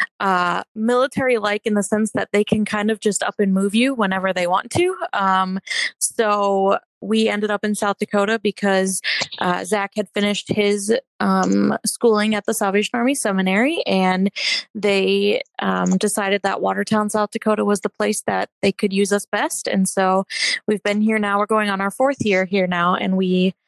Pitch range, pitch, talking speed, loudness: 195-215 Hz, 205 Hz, 190 wpm, -19 LUFS